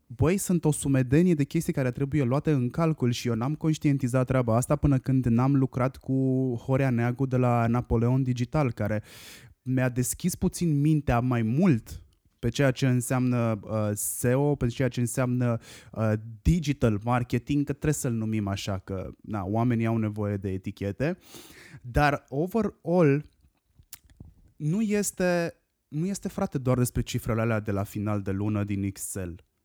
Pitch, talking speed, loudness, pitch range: 125 Hz, 160 wpm, -27 LUFS, 110-145 Hz